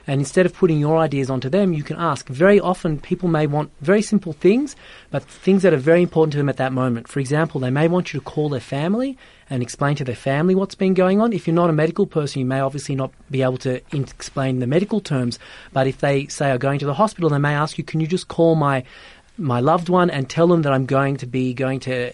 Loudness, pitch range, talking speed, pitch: -20 LUFS, 135-175 Hz, 265 wpm, 150 Hz